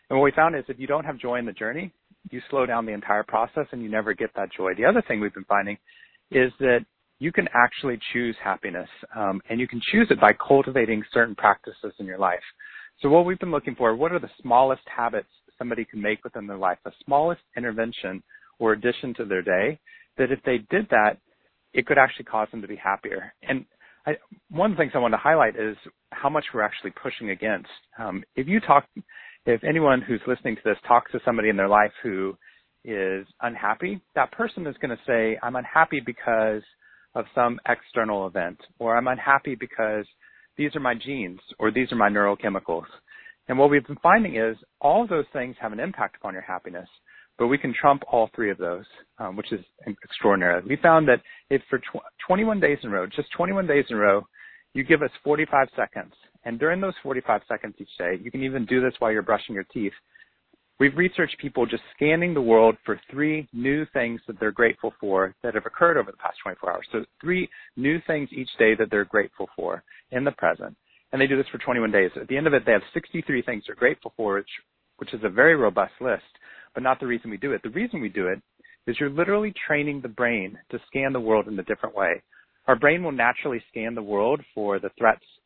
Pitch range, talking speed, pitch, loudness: 110-145 Hz, 225 wpm, 125 Hz, -24 LUFS